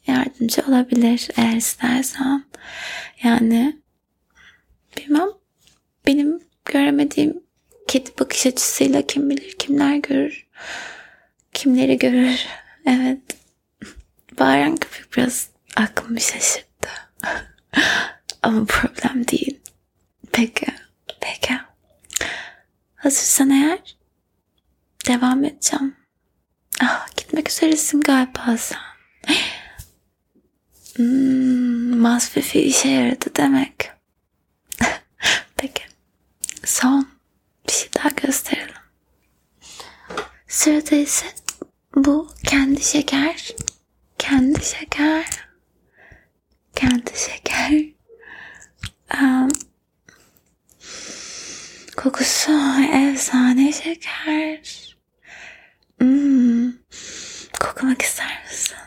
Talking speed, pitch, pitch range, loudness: 65 wpm, 275 Hz, 255-305 Hz, -19 LUFS